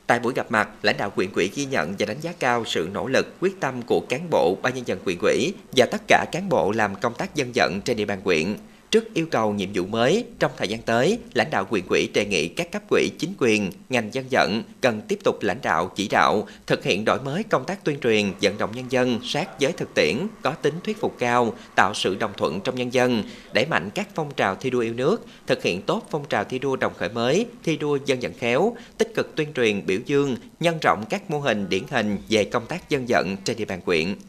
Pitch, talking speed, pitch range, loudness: 130 Hz, 255 wpm, 115-165 Hz, -23 LUFS